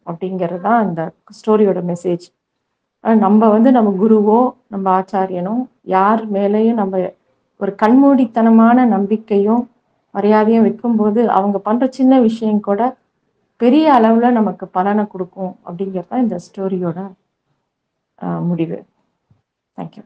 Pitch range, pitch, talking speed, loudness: 190-230 Hz, 210 Hz, 100 wpm, -15 LUFS